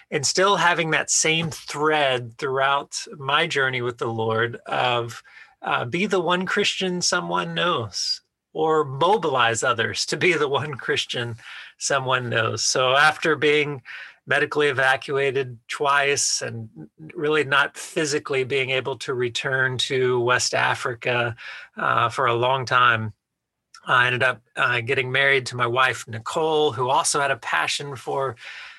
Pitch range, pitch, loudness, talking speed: 125-155 Hz, 135 Hz, -21 LUFS, 140 wpm